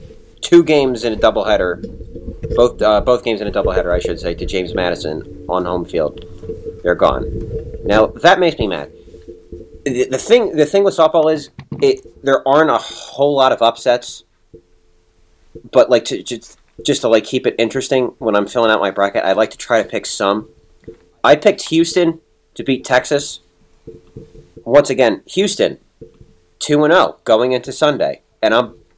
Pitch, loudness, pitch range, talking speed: 120 Hz, -15 LUFS, 90-145 Hz, 170 wpm